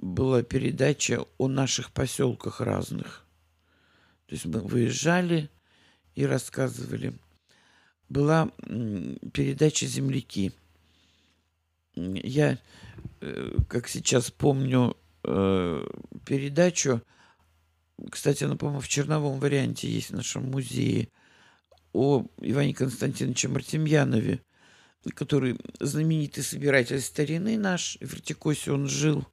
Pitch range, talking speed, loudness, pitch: 100-145 Hz, 90 wpm, -27 LUFS, 130 Hz